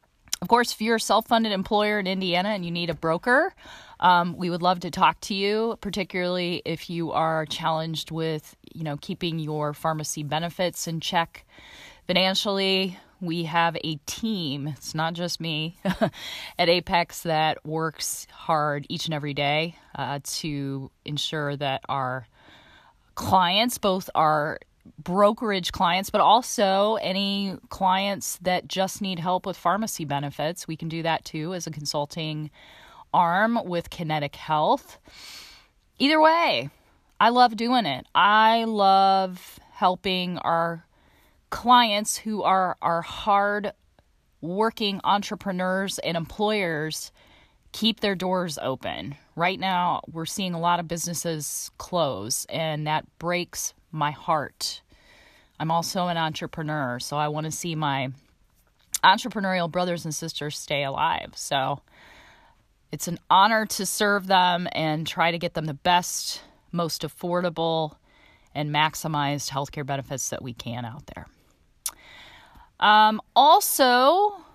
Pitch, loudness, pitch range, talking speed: 175 Hz, -24 LUFS, 155-195 Hz, 135 wpm